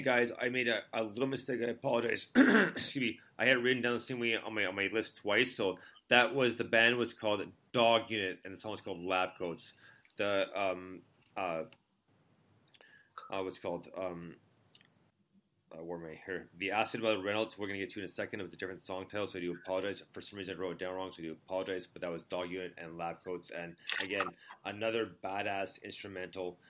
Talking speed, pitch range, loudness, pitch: 220 wpm, 90-115 Hz, -34 LUFS, 100 Hz